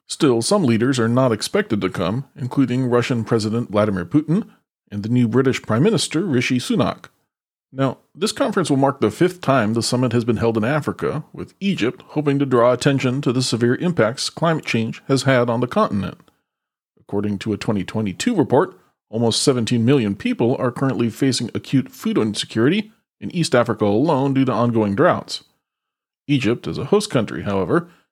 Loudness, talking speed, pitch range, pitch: -19 LUFS, 175 wpm, 115-145 Hz, 125 Hz